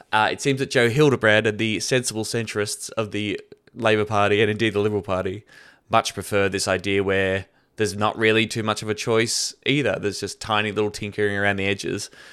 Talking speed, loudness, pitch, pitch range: 200 wpm, -22 LUFS, 105 Hz, 100-115 Hz